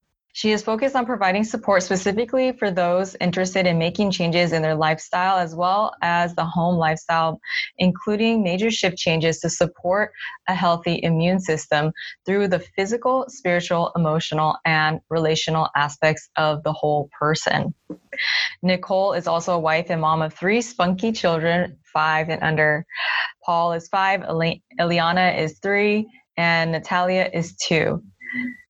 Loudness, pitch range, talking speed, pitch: -21 LUFS, 160-195 Hz, 140 wpm, 175 Hz